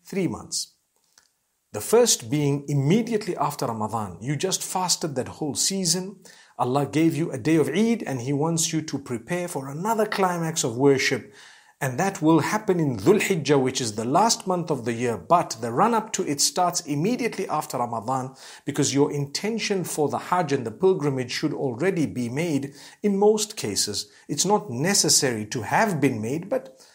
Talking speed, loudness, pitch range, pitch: 180 wpm, -24 LUFS, 135-190 Hz, 150 Hz